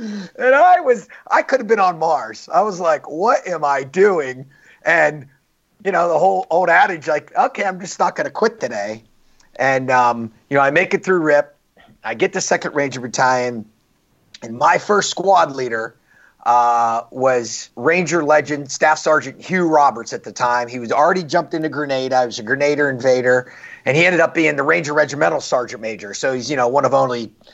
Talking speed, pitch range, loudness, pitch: 200 wpm, 125-175 Hz, -17 LUFS, 145 Hz